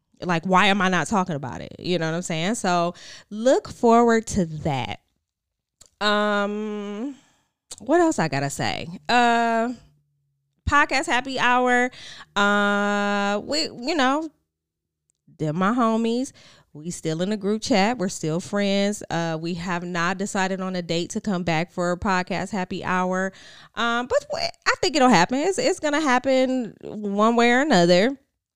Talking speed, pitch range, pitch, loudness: 160 wpm, 170-235 Hz, 200 Hz, -22 LUFS